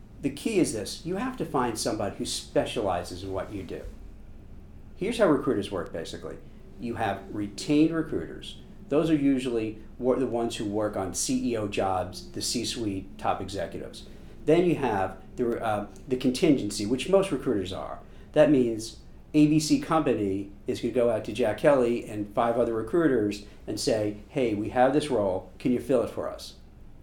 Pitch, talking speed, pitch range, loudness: 115 Hz, 175 wpm, 100-130 Hz, -27 LUFS